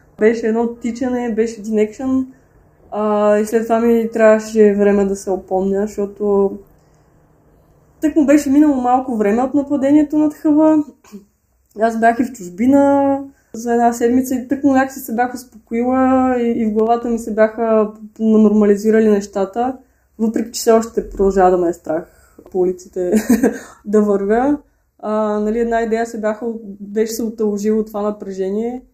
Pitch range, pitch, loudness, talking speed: 210-250 Hz, 225 Hz, -16 LUFS, 150 wpm